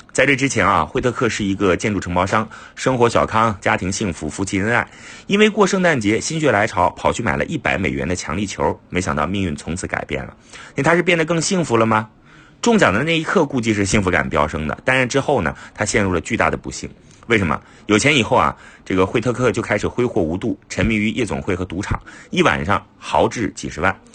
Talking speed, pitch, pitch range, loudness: 340 characters per minute, 110 Hz, 95-130 Hz, -18 LUFS